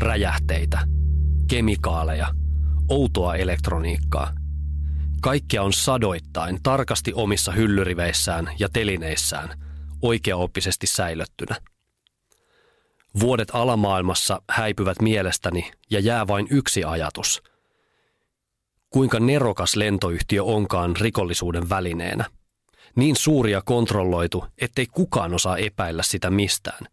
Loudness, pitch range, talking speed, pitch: -22 LUFS, 80-110 Hz, 85 wpm, 95 Hz